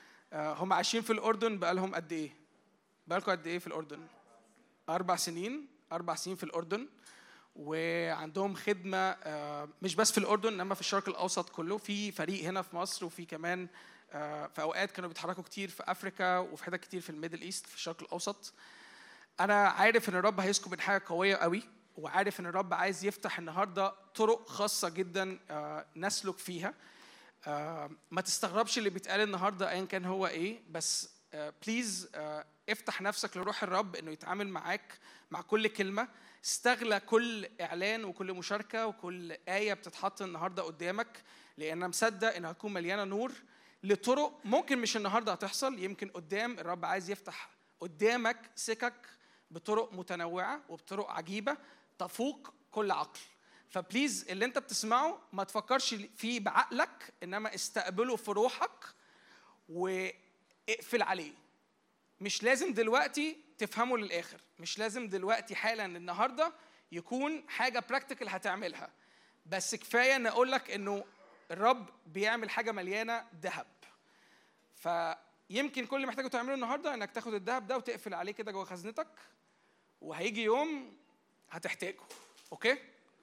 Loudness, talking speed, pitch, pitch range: -35 LUFS, 135 wpm, 200 Hz, 180-225 Hz